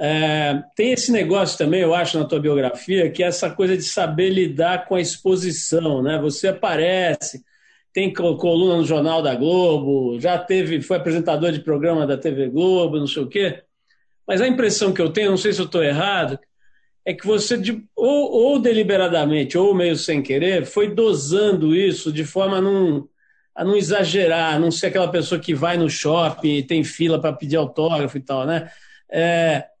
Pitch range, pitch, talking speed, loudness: 155-190 Hz, 170 Hz, 185 wpm, -19 LUFS